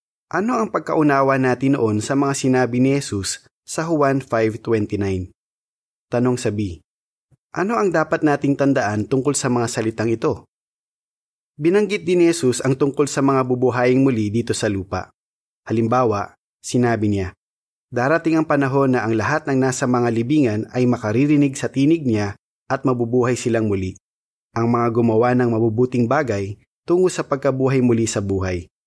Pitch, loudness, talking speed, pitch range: 125 Hz, -19 LUFS, 150 wpm, 110-140 Hz